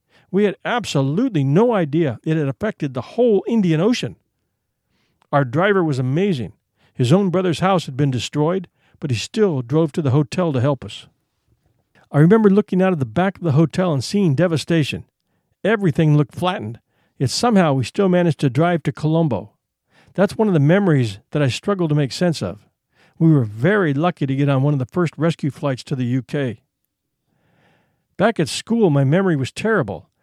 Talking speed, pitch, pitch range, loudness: 185 wpm, 155 Hz, 135-180 Hz, -19 LUFS